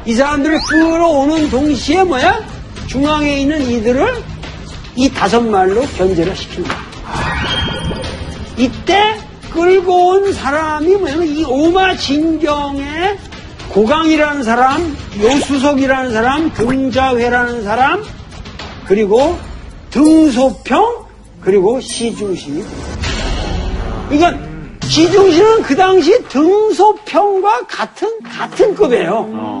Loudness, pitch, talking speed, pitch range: -13 LUFS, 300 Hz, 220 characters per minute, 260-370 Hz